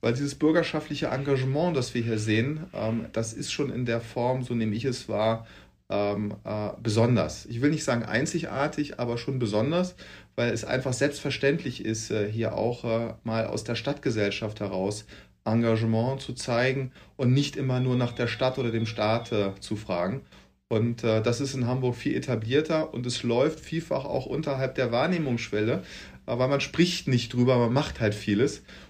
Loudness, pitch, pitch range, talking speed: -27 LUFS, 120 Hz, 110-135 Hz, 165 wpm